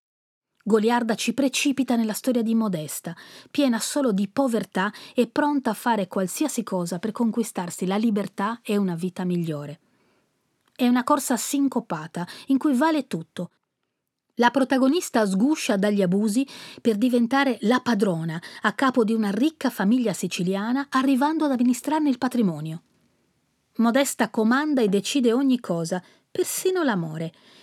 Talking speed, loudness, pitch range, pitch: 135 wpm, -23 LUFS, 195-265 Hz, 235 Hz